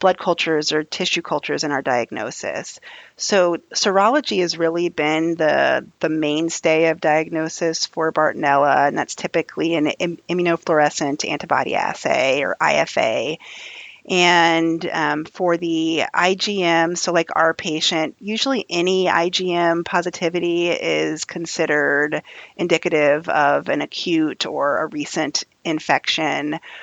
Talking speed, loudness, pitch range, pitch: 120 wpm, -19 LUFS, 155-175 Hz, 165 Hz